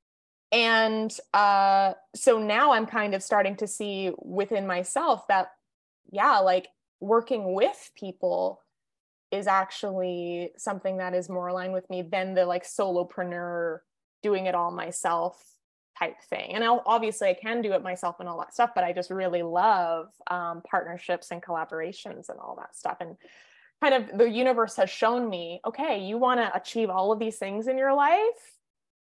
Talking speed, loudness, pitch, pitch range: 170 wpm, -26 LUFS, 195 Hz, 180-225 Hz